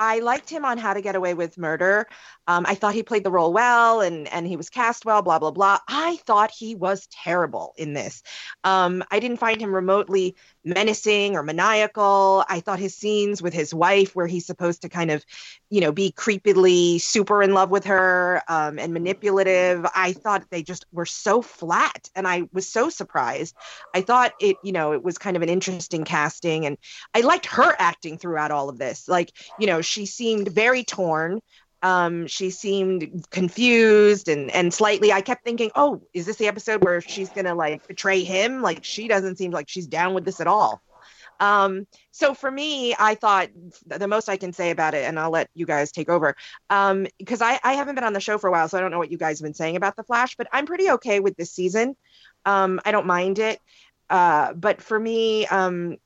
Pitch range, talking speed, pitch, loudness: 175-215 Hz, 215 wpm, 190 Hz, -22 LUFS